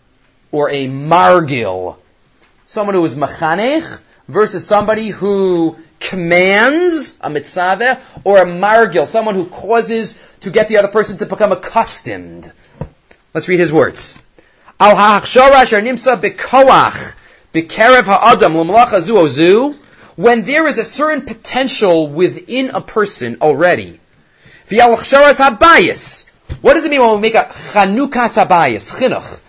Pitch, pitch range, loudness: 205 Hz, 170-240 Hz, -11 LUFS